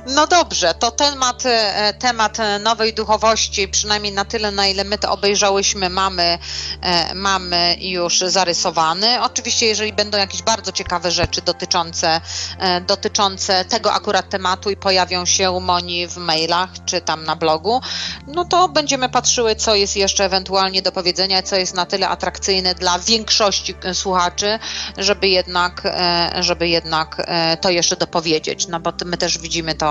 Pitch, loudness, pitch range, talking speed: 190 Hz, -17 LUFS, 175-210 Hz, 145 wpm